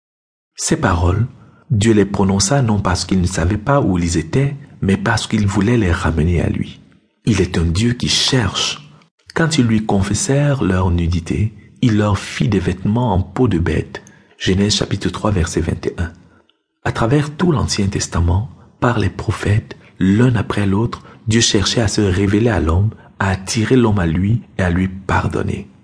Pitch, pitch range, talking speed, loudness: 105 Hz, 95-115 Hz, 175 wpm, -17 LUFS